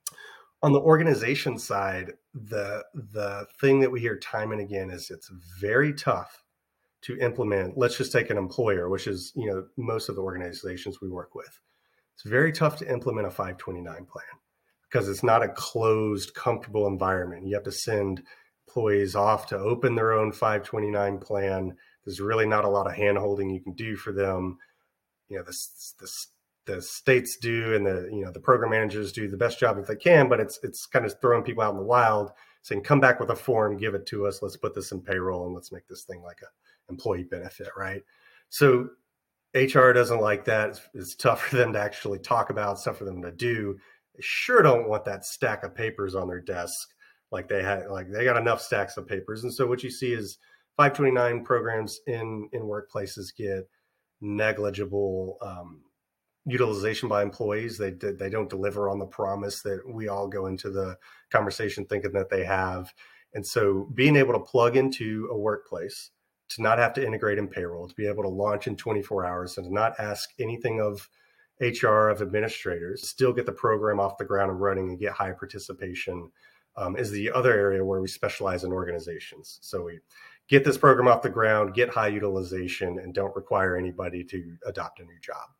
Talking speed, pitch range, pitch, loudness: 200 wpm, 95-115 Hz, 105 Hz, -26 LUFS